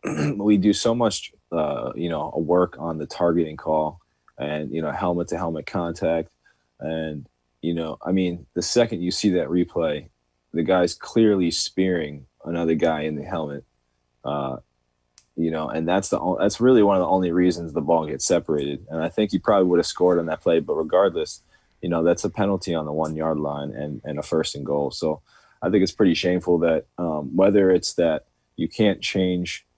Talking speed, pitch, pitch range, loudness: 195 wpm, 80 Hz, 75-90 Hz, -23 LUFS